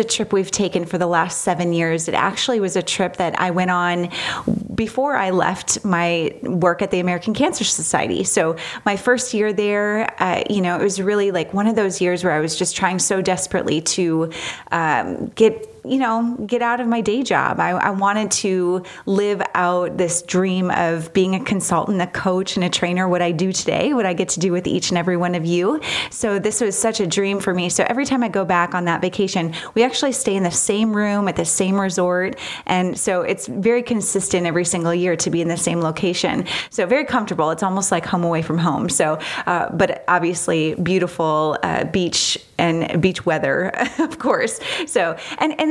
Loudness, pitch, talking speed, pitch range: -19 LUFS, 185 Hz, 215 wpm, 175-210 Hz